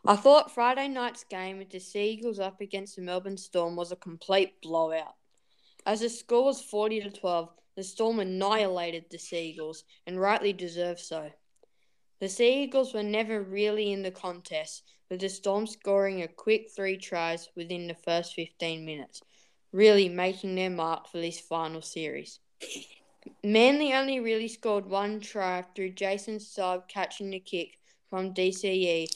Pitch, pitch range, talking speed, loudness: 190 Hz, 175-210 Hz, 155 wpm, -29 LUFS